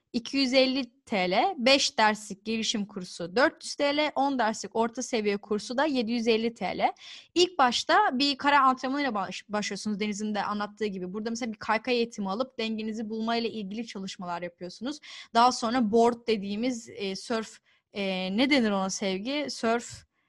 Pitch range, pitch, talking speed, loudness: 205-260 Hz, 230 Hz, 145 wpm, -27 LUFS